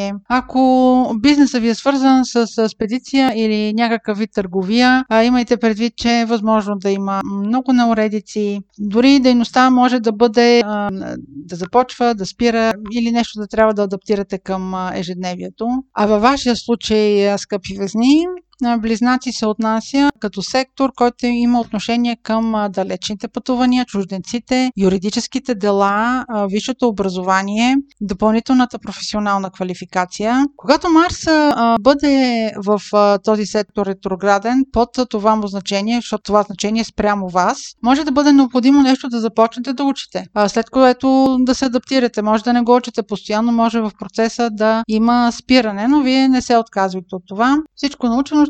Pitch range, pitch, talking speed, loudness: 205-255 Hz, 230 Hz, 140 wpm, -16 LUFS